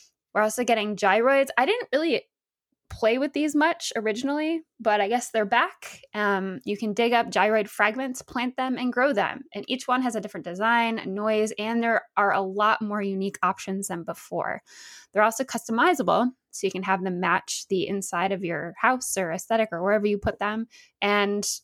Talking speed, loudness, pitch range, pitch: 190 wpm, -25 LUFS, 200-250 Hz, 220 Hz